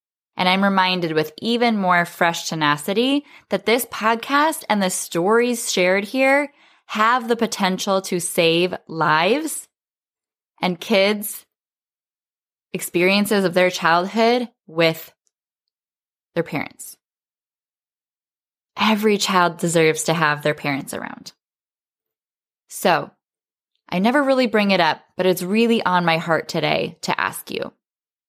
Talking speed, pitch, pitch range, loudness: 120 wpm, 190 Hz, 170-230 Hz, -19 LUFS